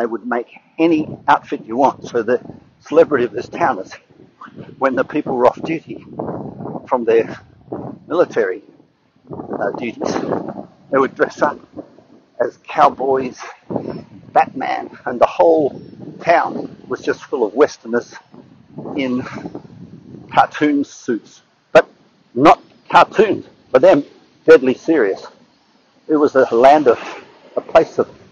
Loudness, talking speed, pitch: -16 LUFS, 125 wpm, 150 Hz